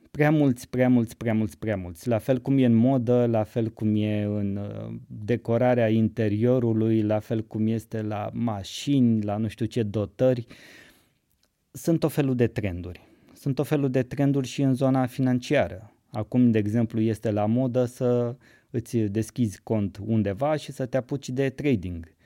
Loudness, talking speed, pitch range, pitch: -25 LUFS, 170 wpm, 110-130 Hz, 115 Hz